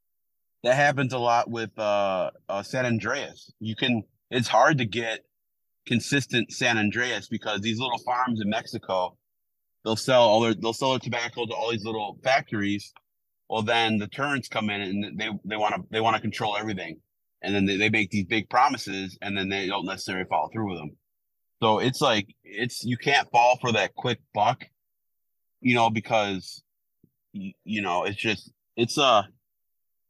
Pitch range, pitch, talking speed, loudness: 105-120 Hz, 110 Hz, 185 wpm, -25 LUFS